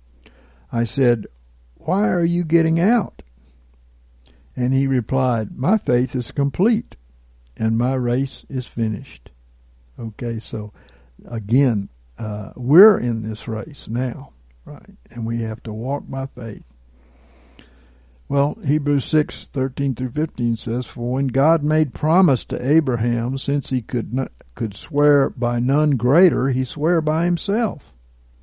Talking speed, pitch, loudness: 135 wpm, 120 Hz, -20 LUFS